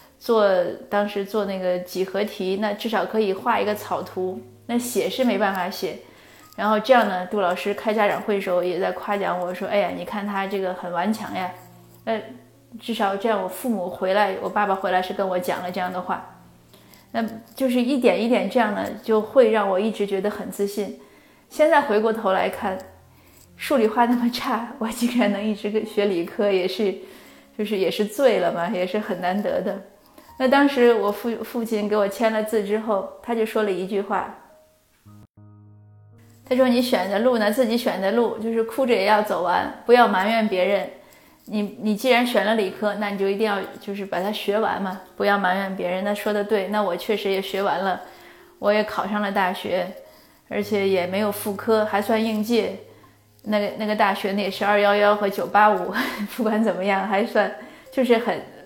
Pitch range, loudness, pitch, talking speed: 190-225 Hz, -22 LUFS, 205 Hz, 275 characters per minute